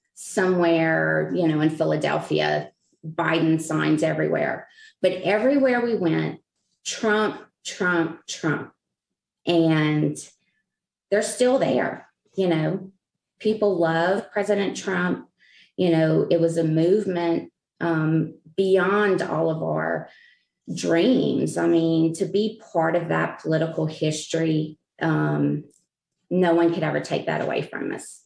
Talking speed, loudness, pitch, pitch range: 120 wpm, -23 LUFS, 165 Hz, 155-195 Hz